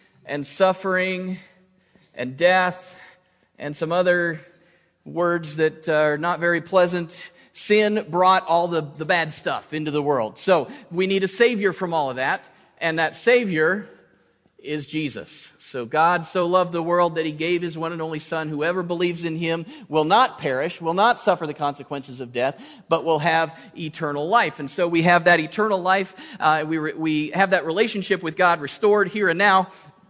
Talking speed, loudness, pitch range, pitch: 180 wpm, -21 LUFS, 155-185 Hz, 170 Hz